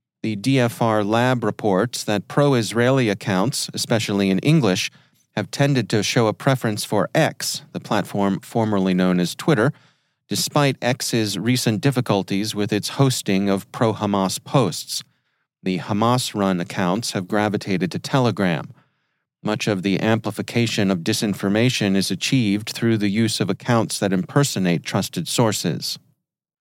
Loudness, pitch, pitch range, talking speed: -21 LUFS, 110 Hz, 100-125 Hz, 140 wpm